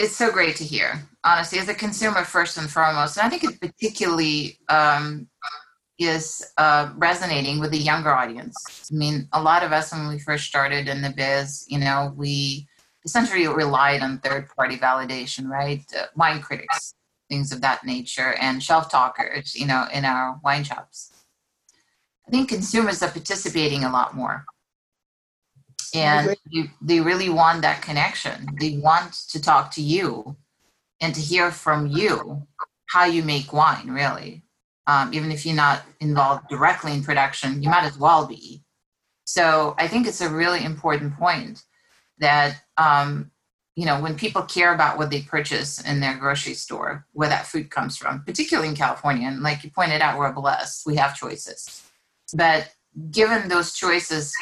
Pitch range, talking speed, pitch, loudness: 140-165 Hz, 170 wpm, 150 Hz, -21 LUFS